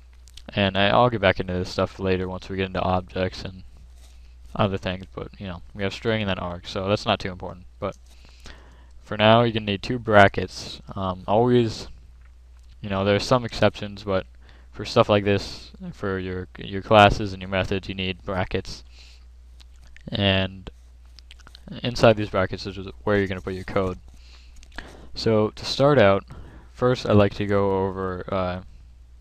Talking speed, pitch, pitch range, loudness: 175 wpm, 95 Hz, 65-100 Hz, -23 LUFS